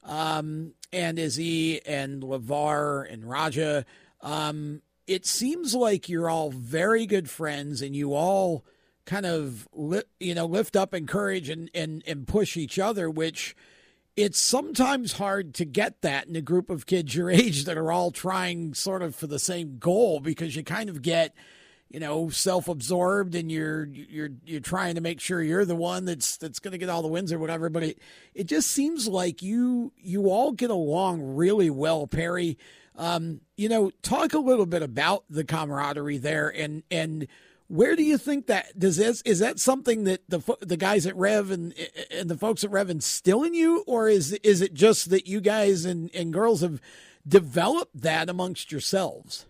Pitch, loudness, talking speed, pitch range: 175 Hz, -26 LUFS, 185 wpm, 155-200 Hz